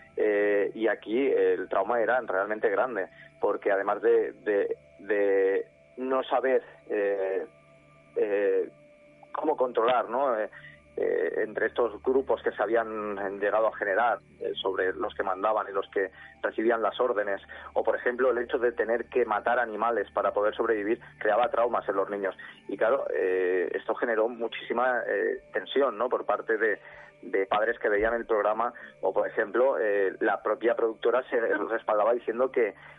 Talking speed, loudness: 155 wpm, -28 LUFS